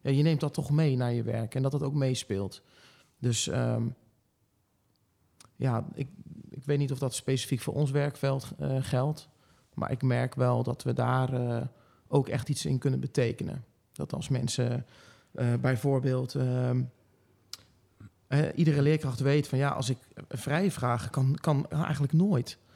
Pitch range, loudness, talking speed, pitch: 120-145 Hz, -30 LUFS, 165 wpm, 130 Hz